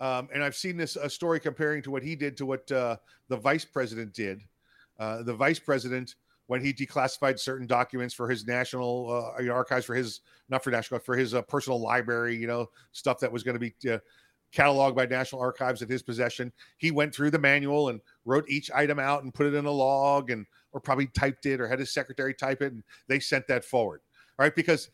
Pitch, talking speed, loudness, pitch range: 130 Hz, 230 wpm, -29 LUFS, 125-140 Hz